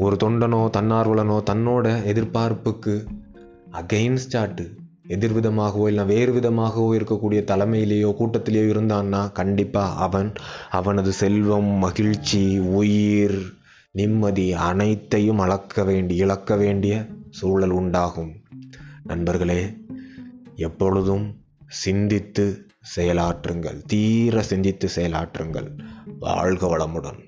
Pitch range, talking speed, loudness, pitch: 95-110 Hz, 80 wpm, -22 LUFS, 105 Hz